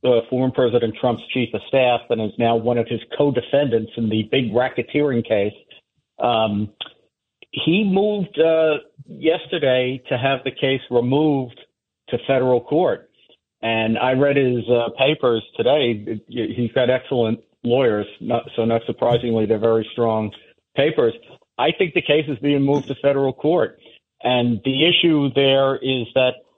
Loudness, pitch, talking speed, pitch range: -20 LUFS, 125 Hz, 150 wpm, 115-140 Hz